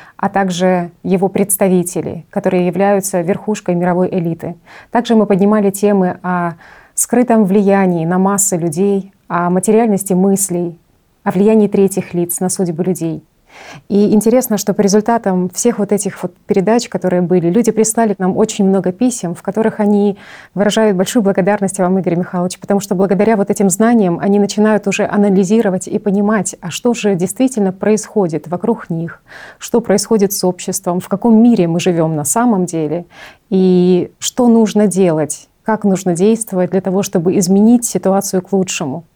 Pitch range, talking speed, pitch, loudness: 180-210 Hz, 155 wpm, 195 Hz, -14 LUFS